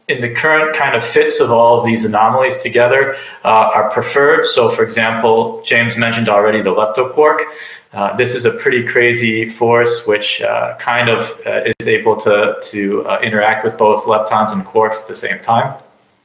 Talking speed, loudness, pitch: 185 wpm, -13 LUFS, 130 Hz